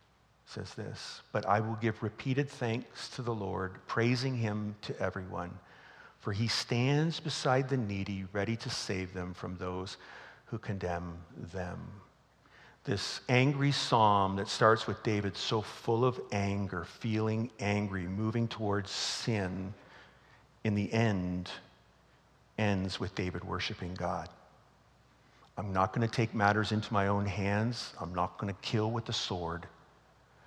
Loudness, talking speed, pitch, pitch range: -33 LUFS, 140 wpm, 105 Hz, 95-115 Hz